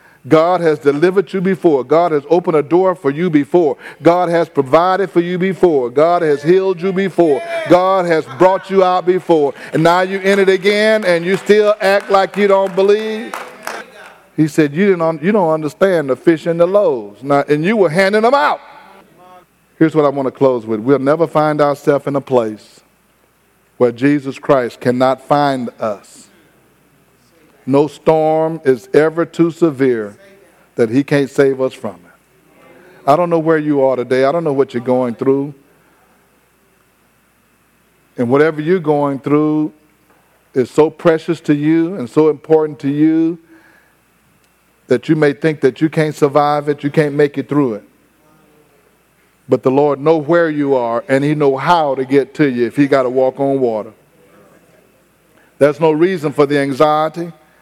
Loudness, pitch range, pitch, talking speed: -14 LUFS, 140-175 Hz, 155 Hz, 175 wpm